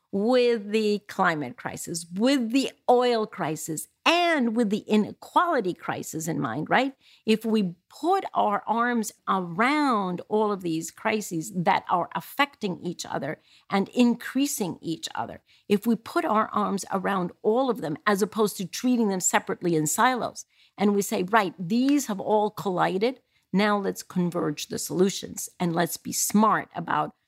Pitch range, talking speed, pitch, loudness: 185-240 Hz, 155 wpm, 210 Hz, -26 LUFS